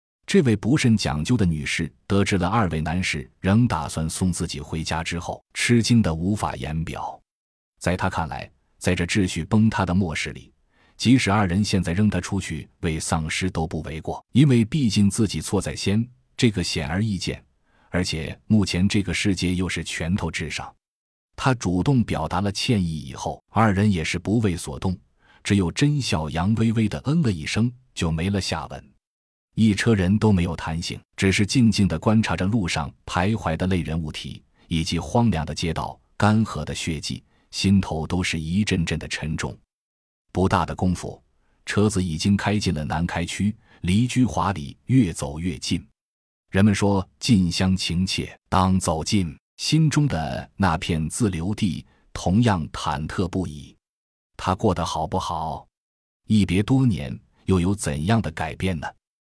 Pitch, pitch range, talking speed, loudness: 95 Hz, 80-105 Hz, 245 characters per minute, -23 LUFS